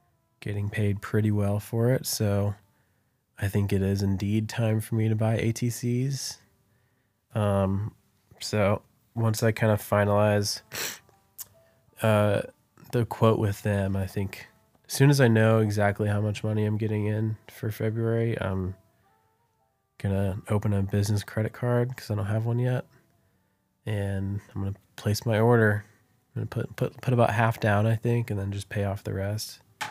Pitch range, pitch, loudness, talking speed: 100-115 Hz, 110 Hz, -27 LUFS, 165 wpm